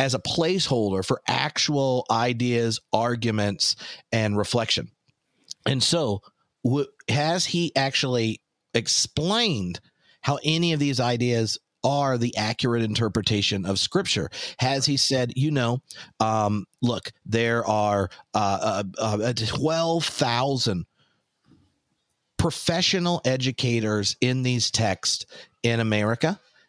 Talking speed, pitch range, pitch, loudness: 105 wpm, 110-140 Hz, 120 Hz, -24 LUFS